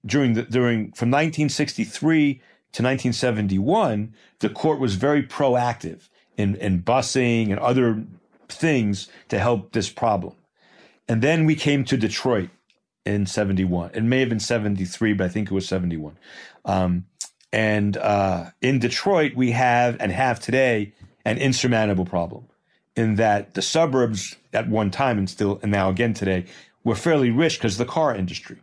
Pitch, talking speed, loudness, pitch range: 115 Hz, 155 wpm, -22 LUFS, 100-130 Hz